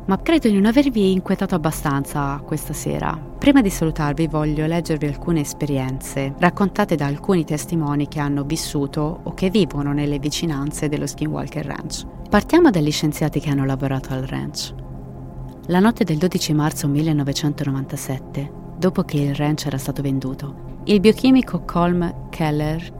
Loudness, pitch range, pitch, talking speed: -20 LUFS, 140-175 Hz, 150 Hz, 145 wpm